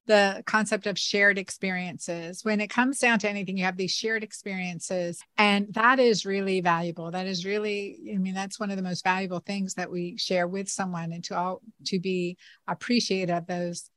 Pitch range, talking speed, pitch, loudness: 180-210 Hz, 200 wpm, 195 Hz, -27 LUFS